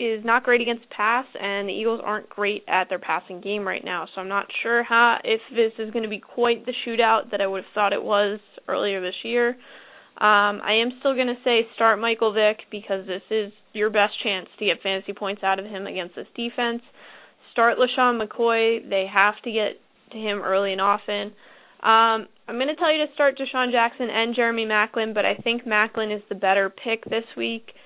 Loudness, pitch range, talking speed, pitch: -23 LUFS, 200-235 Hz, 220 wpm, 220 Hz